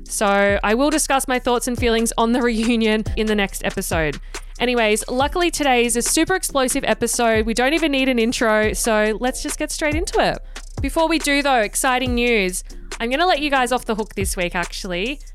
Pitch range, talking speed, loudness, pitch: 220-280 Hz, 205 wpm, -19 LUFS, 240 Hz